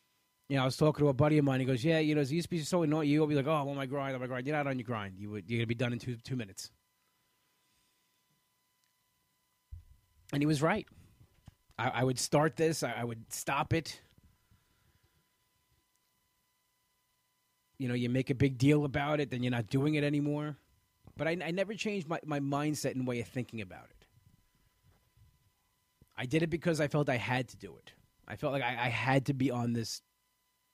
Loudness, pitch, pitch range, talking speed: -32 LUFS, 135 Hz, 120-150 Hz, 215 wpm